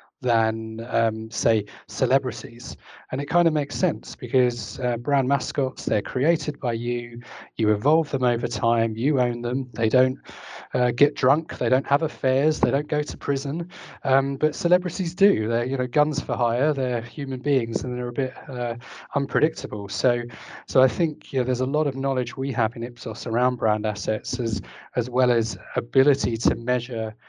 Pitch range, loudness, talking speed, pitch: 120-140 Hz, -24 LUFS, 185 wpm, 125 Hz